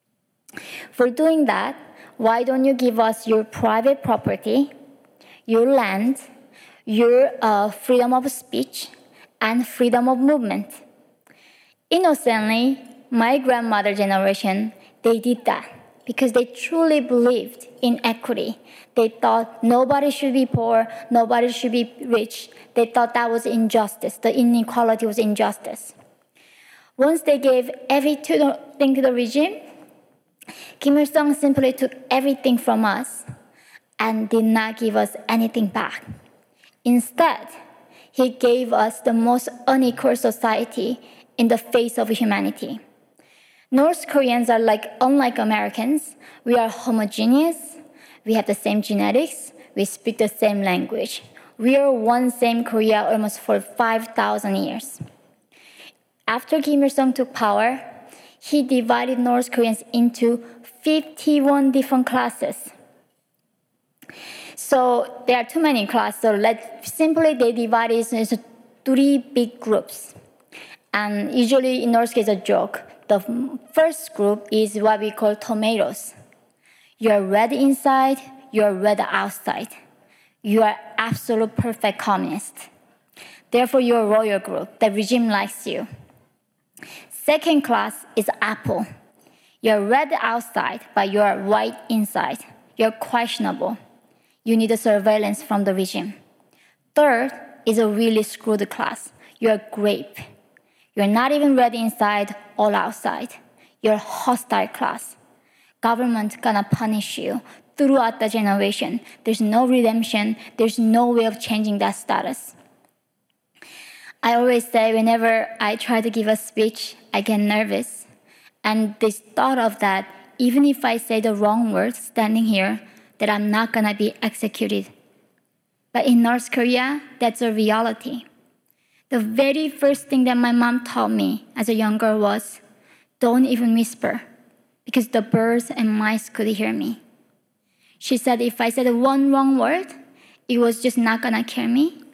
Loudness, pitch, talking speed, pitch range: -20 LUFS, 235 Hz, 135 wpm, 220-260 Hz